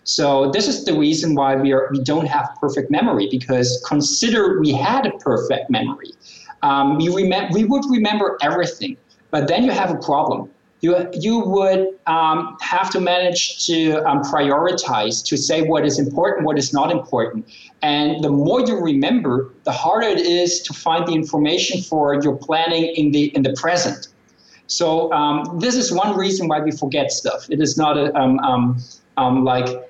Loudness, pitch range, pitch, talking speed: -18 LUFS, 145-190 Hz, 160 Hz, 185 wpm